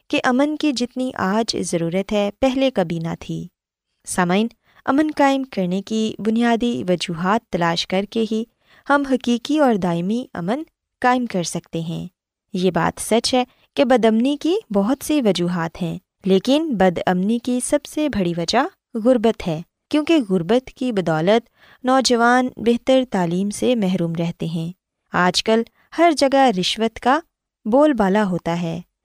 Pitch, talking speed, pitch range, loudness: 225 Hz, 155 wpm, 180-260 Hz, -20 LUFS